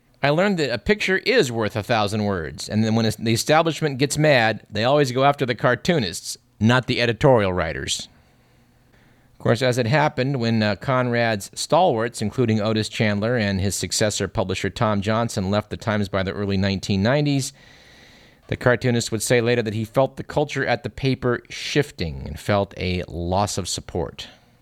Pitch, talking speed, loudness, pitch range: 115 Hz, 175 wpm, -21 LUFS, 100-130 Hz